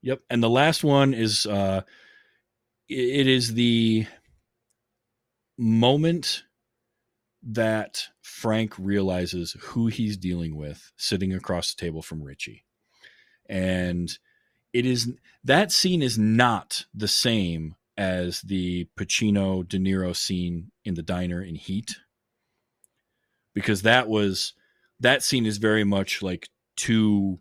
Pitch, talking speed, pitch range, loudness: 110 Hz, 120 wpm, 95-120 Hz, -24 LUFS